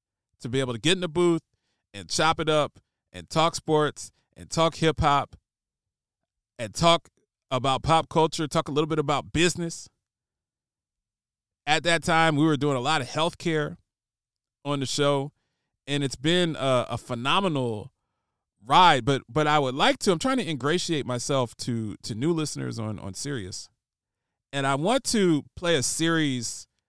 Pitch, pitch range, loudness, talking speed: 140 Hz, 115-160 Hz, -25 LUFS, 165 wpm